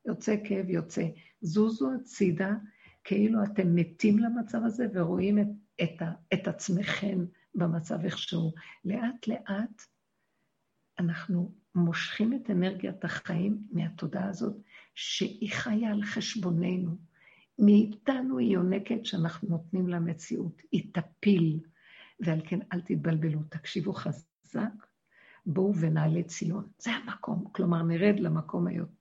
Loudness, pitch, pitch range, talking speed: -30 LUFS, 190 Hz, 170-210 Hz, 110 wpm